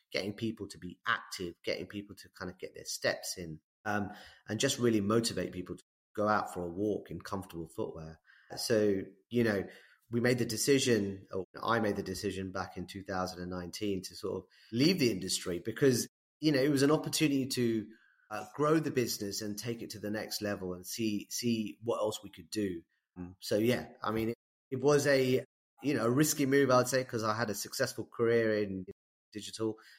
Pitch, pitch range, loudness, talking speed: 105 Hz, 95-120 Hz, -33 LUFS, 200 wpm